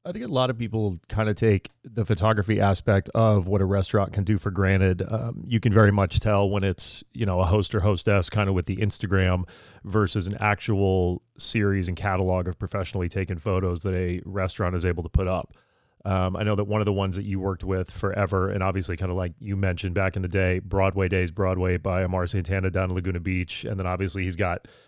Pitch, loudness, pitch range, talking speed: 95 Hz, -25 LUFS, 95-105 Hz, 230 wpm